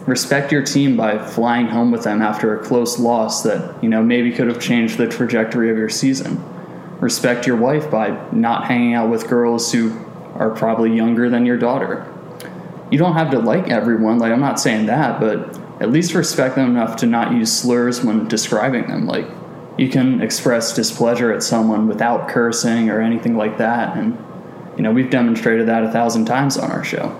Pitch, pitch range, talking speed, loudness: 115 Hz, 115-125 Hz, 195 wpm, -17 LUFS